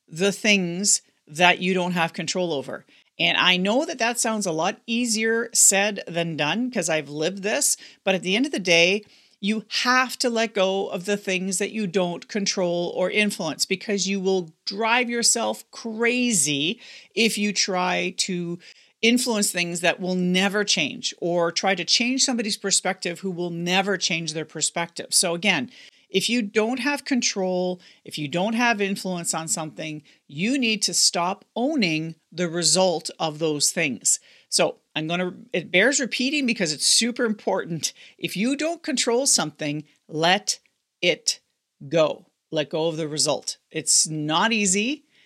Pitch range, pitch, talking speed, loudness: 175-230 Hz, 195 Hz, 165 wpm, -22 LUFS